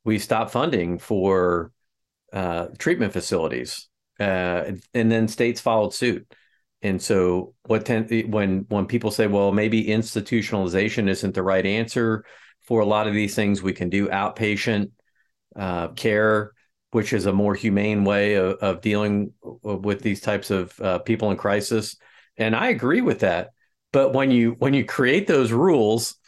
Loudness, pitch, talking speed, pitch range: -22 LUFS, 105 Hz, 160 wpm, 100-110 Hz